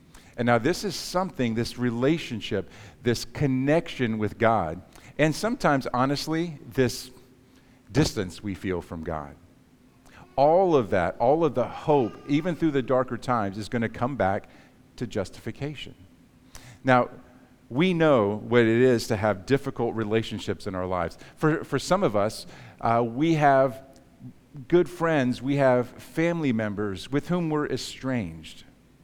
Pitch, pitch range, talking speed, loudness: 125 Hz, 110-140 Hz, 145 wpm, -25 LUFS